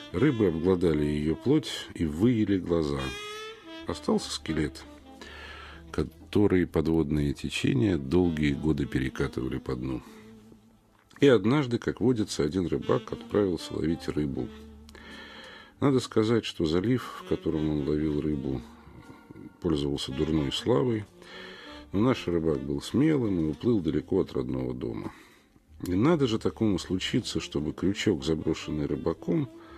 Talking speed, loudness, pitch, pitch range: 115 wpm, -28 LUFS, 80 Hz, 75-110 Hz